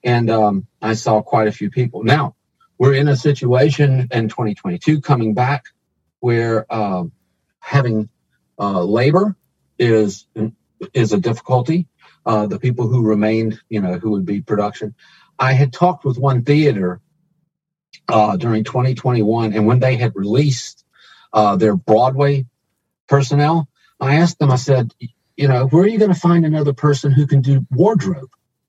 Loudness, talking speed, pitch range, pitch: -16 LUFS, 155 wpm, 110-145 Hz, 125 Hz